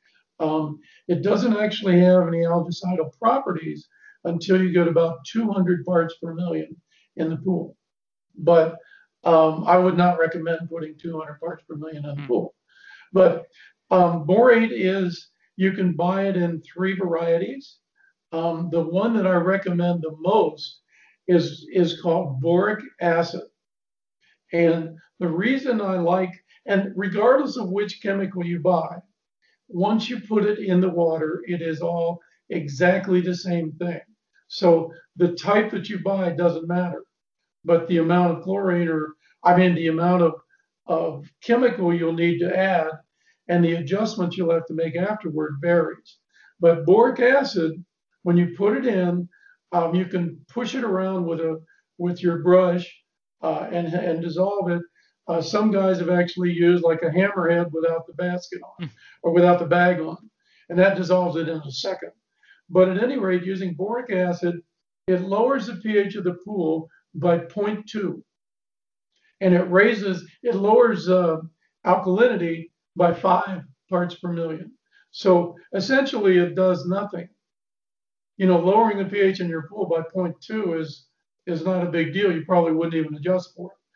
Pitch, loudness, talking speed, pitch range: 175 Hz, -22 LUFS, 160 wpm, 170-195 Hz